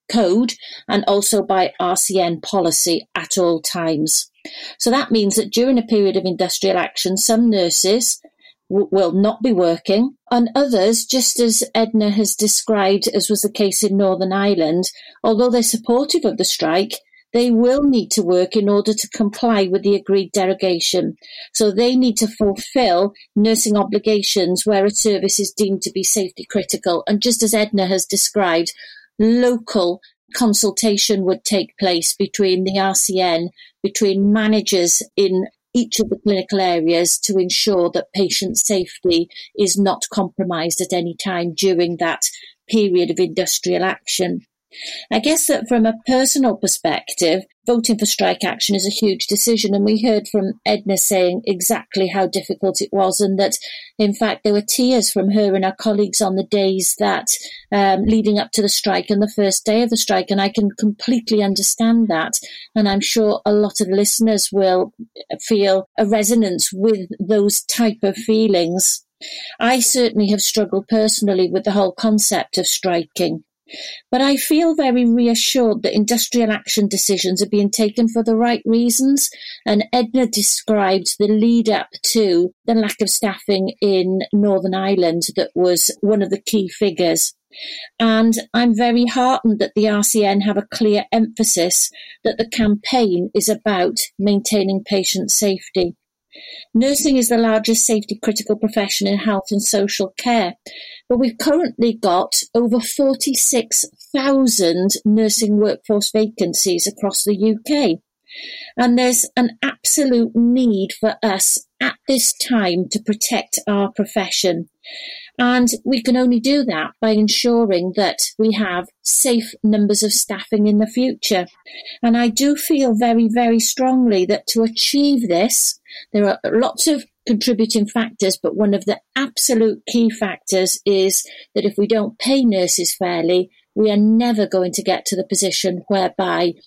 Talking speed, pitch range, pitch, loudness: 155 wpm, 195-230 Hz, 210 Hz, -17 LUFS